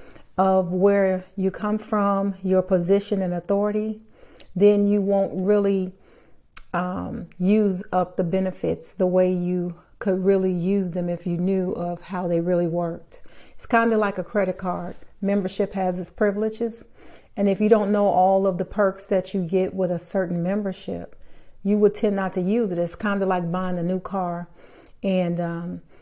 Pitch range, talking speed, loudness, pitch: 180-200 Hz, 180 wpm, -23 LUFS, 190 Hz